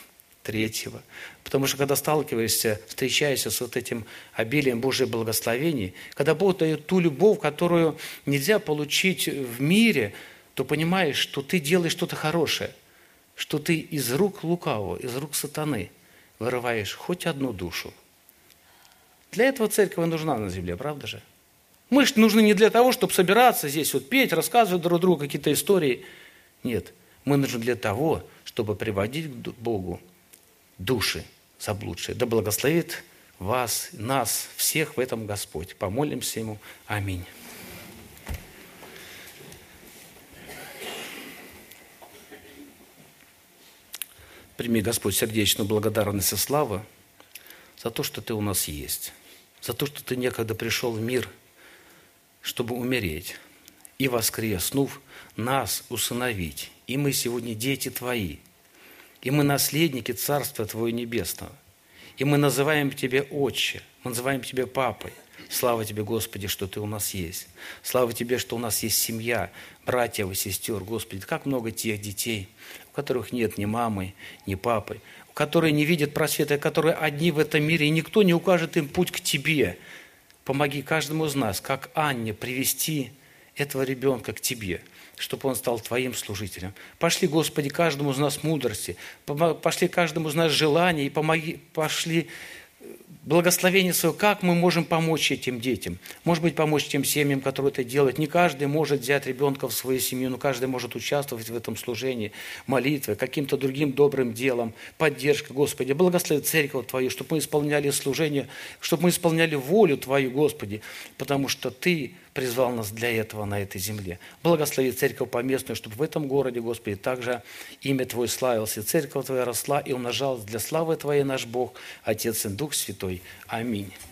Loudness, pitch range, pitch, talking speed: -25 LUFS, 115-155 Hz, 130 Hz, 145 wpm